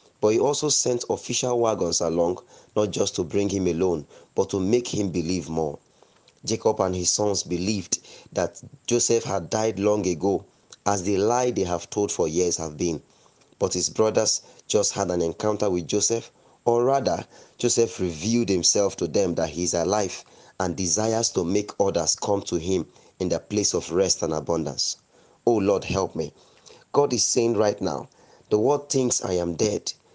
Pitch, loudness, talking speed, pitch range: 100 Hz, -24 LUFS, 180 wpm, 90-115 Hz